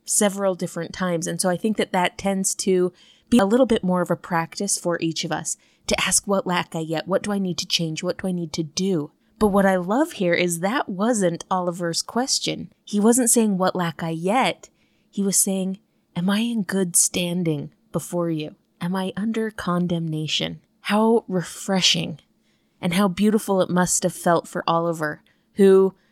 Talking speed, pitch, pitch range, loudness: 195 wpm, 185 Hz, 170-200 Hz, -22 LUFS